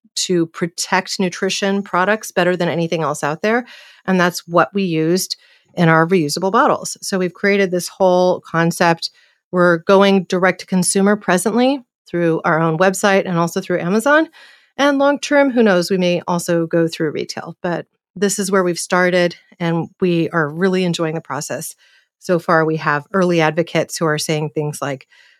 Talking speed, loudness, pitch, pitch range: 175 wpm, -17 LUFS, 180 Hz, 165-195 Hz